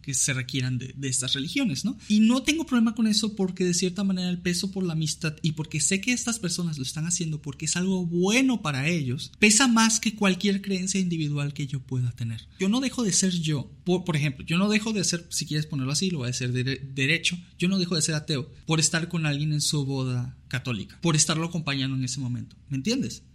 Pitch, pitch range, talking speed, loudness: 165 Hz, 140-190 Hz, 245 wpm, -25 LUFS